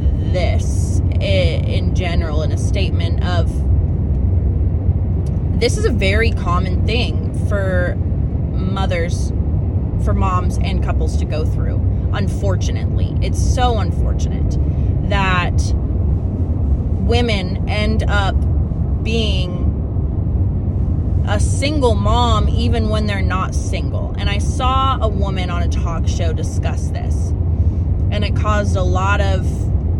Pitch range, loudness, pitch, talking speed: 85-95 Hz, -18 LUFS, 90 Hz, 110 wpm